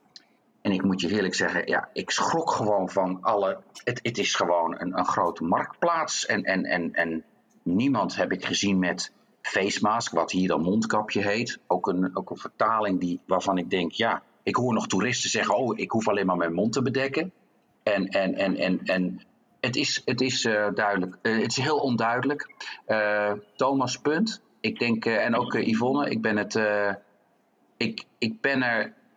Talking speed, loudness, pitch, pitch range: 195 wpm, -26 LUFS, 100 Hz, 95-115 Hz